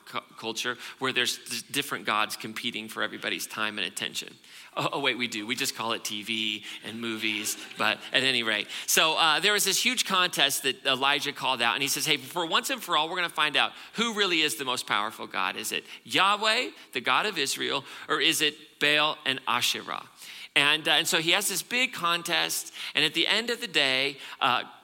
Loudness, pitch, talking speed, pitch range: -26 LUFS, 140 Hz, 215 wpm, 115-170 Hz